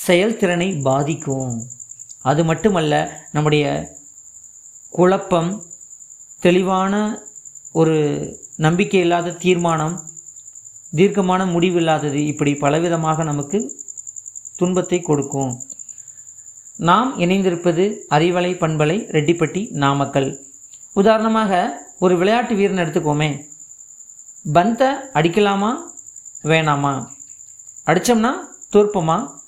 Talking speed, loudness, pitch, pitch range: 70 wpm, -18 LUFS, 160 Hz, 135-185 Hz